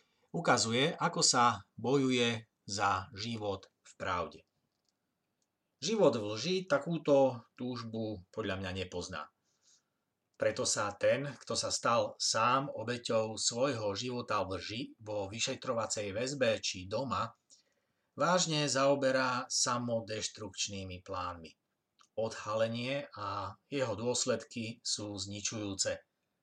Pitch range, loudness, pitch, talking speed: 100-130 Hz, -33 LUFS, 115 Hz, 100 wpm